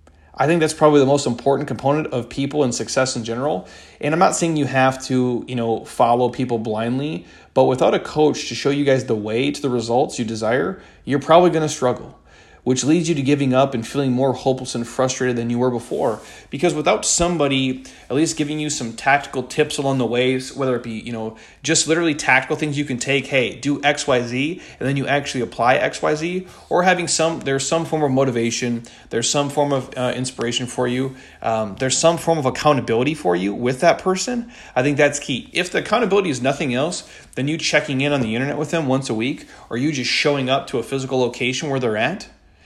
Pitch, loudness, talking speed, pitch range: 135 Hz, -19 LUFS, 220 wpm, 125-150 Hz